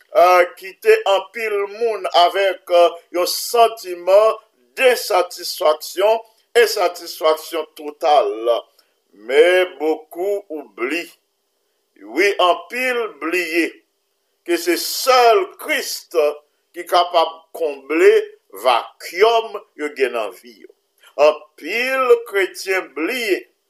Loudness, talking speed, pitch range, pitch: -18 LUFS, 85 wpm, 175-265 Hz, 205 Hz